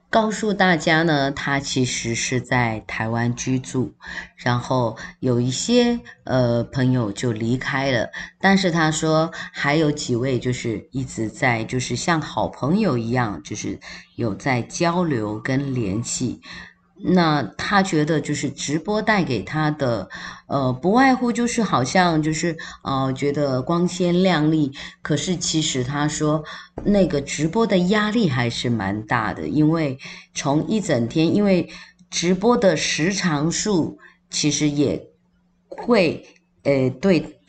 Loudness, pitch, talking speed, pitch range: -21 LUFS, 150 Hz, 195 characters per minute, 125-175 Hz